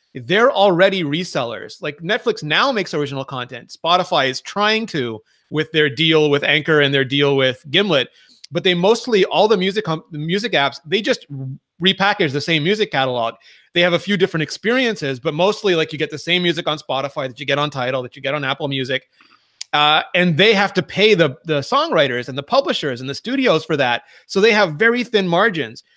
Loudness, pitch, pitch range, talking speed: -17 LUFS, 160 Hz, 140-200 Hz, 205 wpm